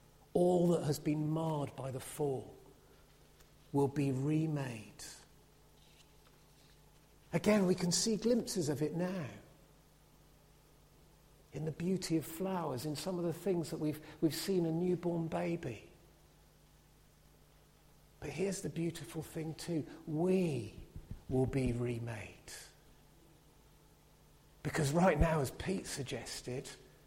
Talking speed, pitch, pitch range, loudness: 115 wpm, 155 Hz, 140-170 Hz, -36 LUFS